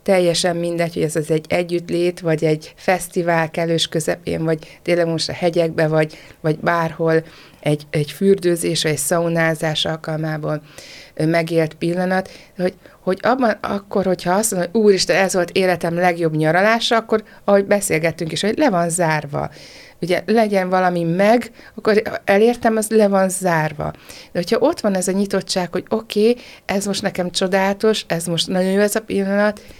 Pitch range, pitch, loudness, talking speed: 165-200 Hz, 180 Hz, -18 LUFS, 165 wpm